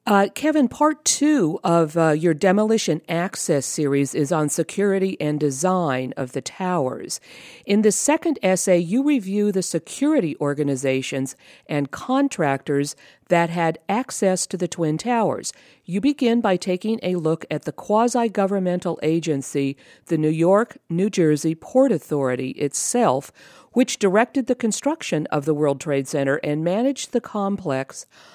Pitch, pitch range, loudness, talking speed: 180 Hz, 150-225 Hz, -21 LUFS, 145 wpm